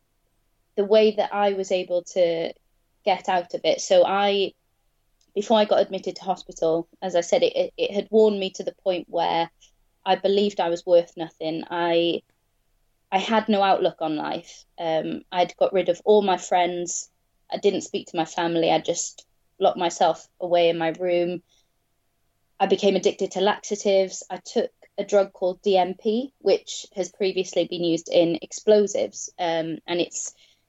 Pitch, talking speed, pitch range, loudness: 180 Hz, 170 wpm, 165-200 Hz, -23 LUFS